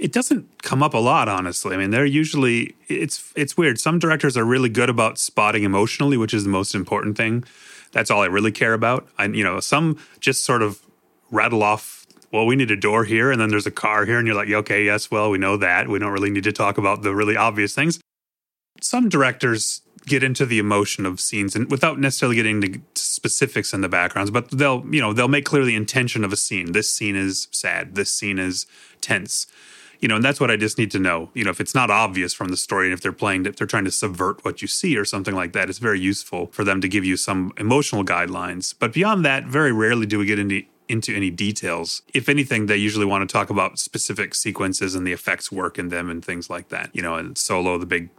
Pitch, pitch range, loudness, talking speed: 105 Hz, 100-130 Hz, -20 LUFS, 245 wpm